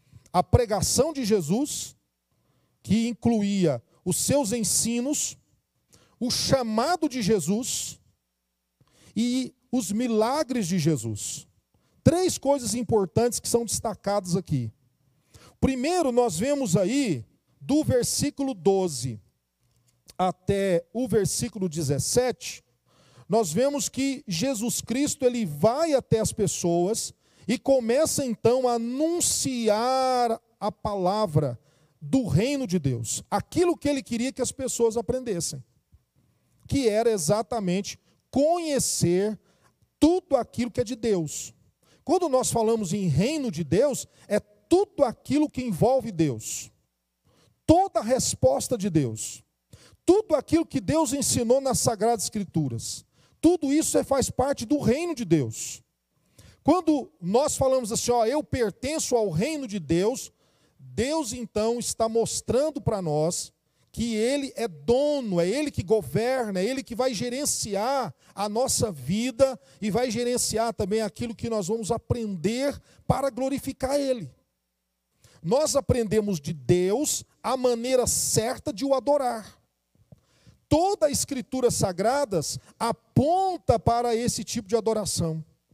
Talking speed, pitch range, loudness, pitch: 120 wpm, 175-260 Hz, -25 LUFS, 225 Hz